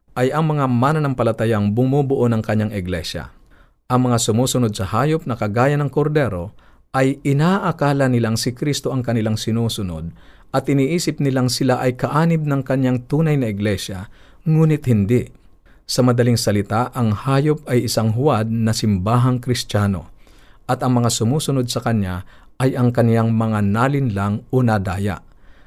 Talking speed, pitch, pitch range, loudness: 145 wpm, 120 Hz, 105-135 Hz, -19 LUFS